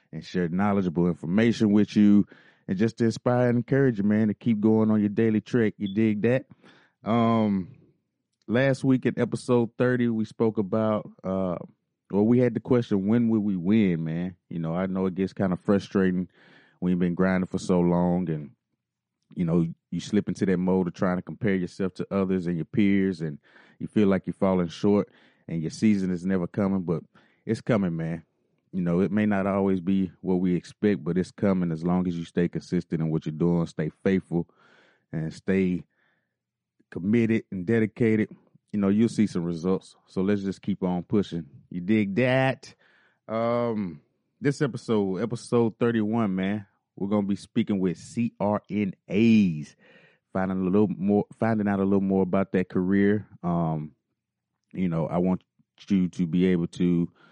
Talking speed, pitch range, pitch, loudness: 180 wpm, 90-110 Hz, 95 Hz, -26 LUFS